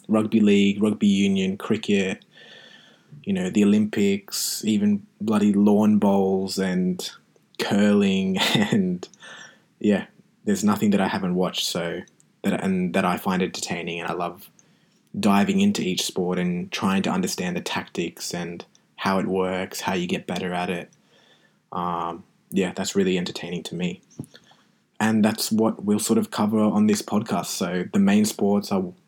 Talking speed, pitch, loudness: 150 wpm, 105 Hz, -23 LUFS